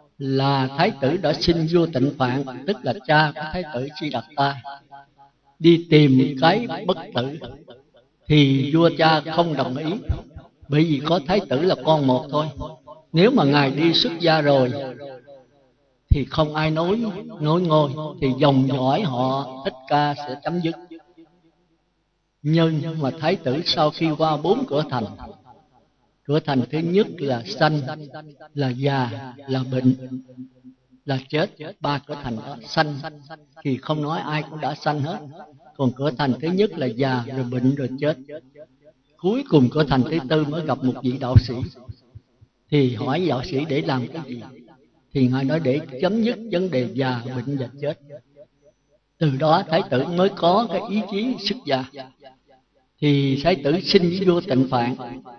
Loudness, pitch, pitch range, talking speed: -21 LUFS, 145 Hz, 130-160 Hz, 170 wpm